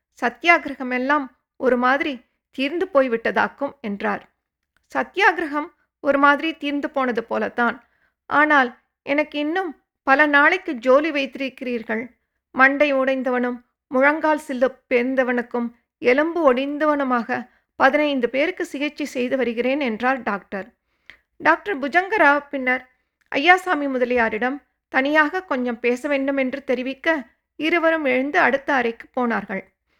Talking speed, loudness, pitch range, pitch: 100 wpm, -20 LUFS, 250-295 Hz, 270 Hz